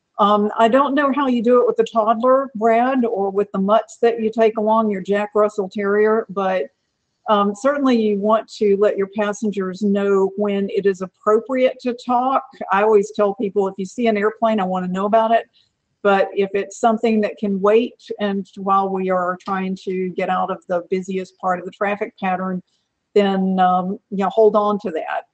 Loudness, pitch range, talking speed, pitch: -19 LUFS, 195-225 Hz, 205 wpm, 205 Hz